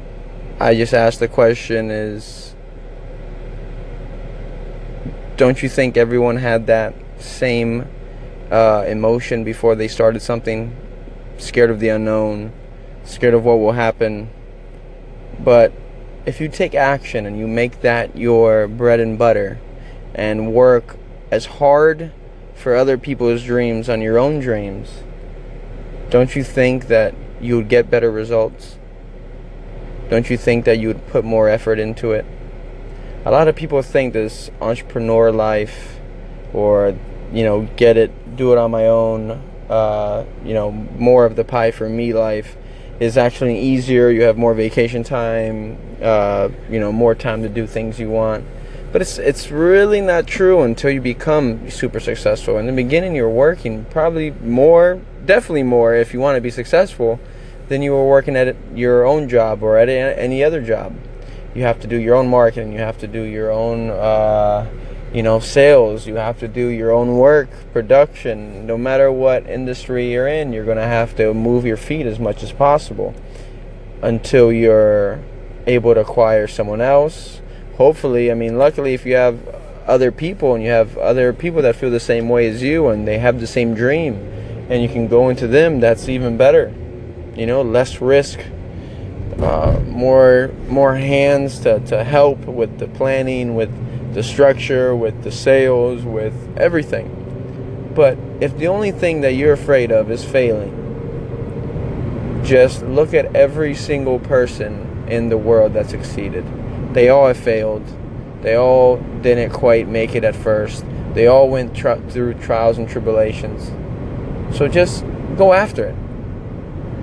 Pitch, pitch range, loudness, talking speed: 120 Hz, 110-130 Hz, -16 LUFS, 160 wpm